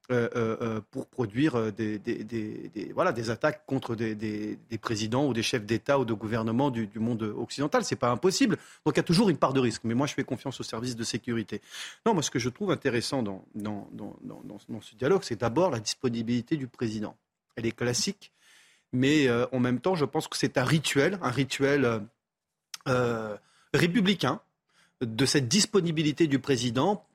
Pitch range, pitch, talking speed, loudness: 115-145 Hz, 125 Hz, 205 wpm, -28 LUFS